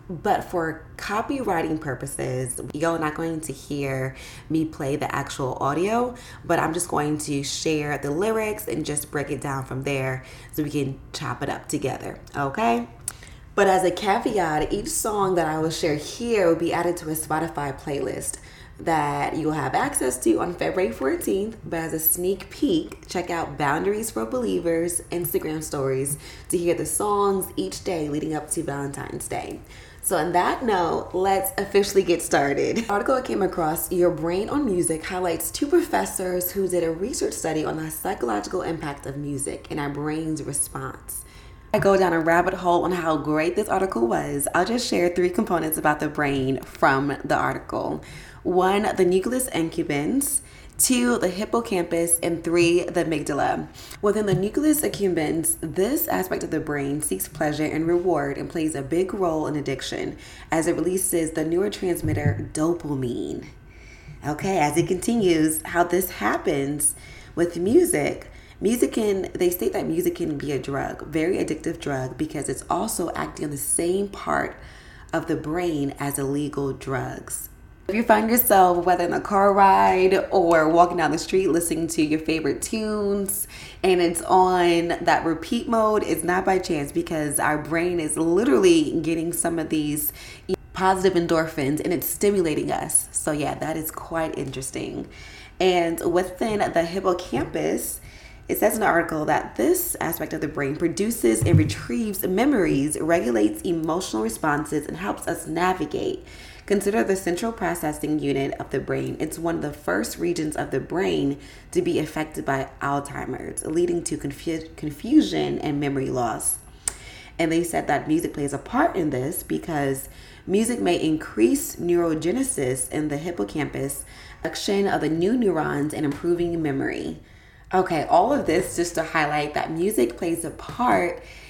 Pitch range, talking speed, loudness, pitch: 150-190 Hz, 165 wpm, -24 LUFS, 165 Hz